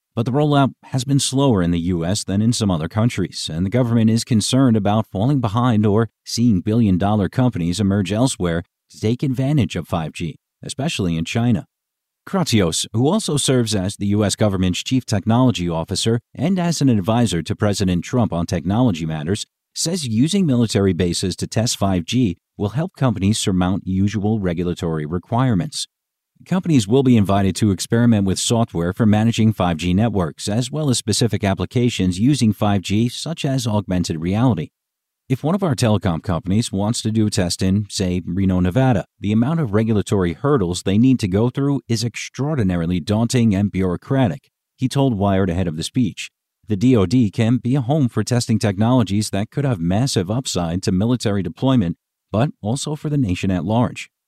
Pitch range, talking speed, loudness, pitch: 95-125 Hz, 170 wpm, -19 LUFS, 110 Hz